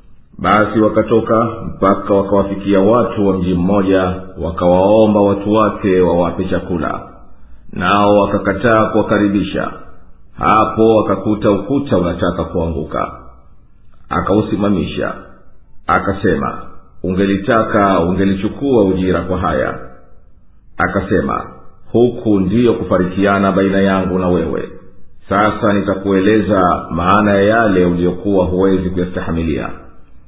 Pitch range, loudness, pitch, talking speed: 90-105 Hz, -14 LUFS, 95 Hz, 85 wpm